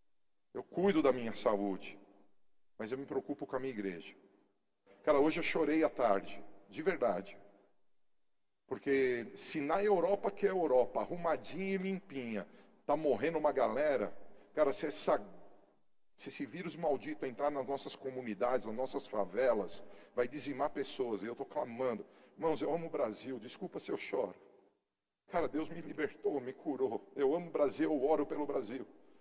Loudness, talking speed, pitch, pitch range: -36 LUFS, 165 wpm, 125 Hz, 100-145 Hz